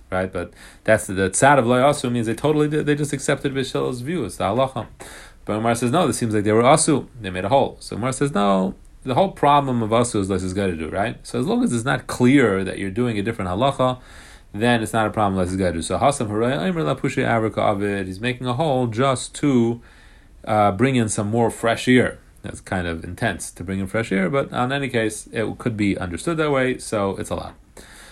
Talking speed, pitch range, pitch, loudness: 245 wpm, 100-135 Hz, 115 Hz, -21 LUFS